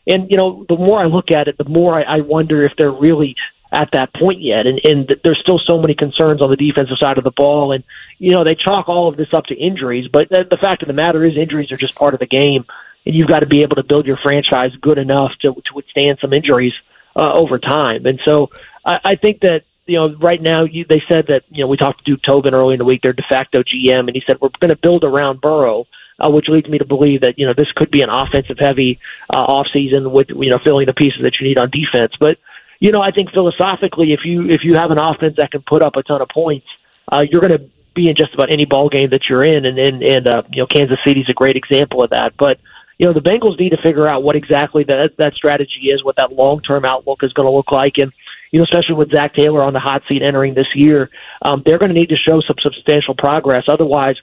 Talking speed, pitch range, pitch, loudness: 270 wpm, 135-160 Hz, 145 Hz, -13 LUFS